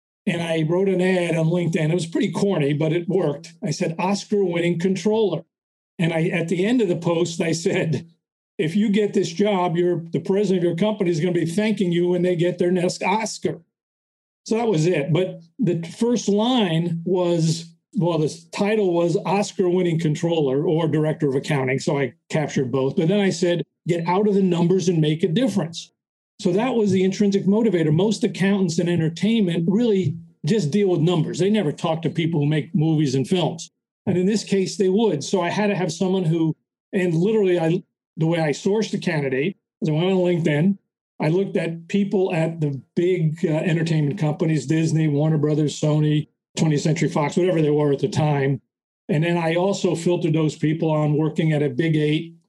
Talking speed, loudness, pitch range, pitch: 200 wpm, -21 LUFS, 160-195 Hz, 175 Hz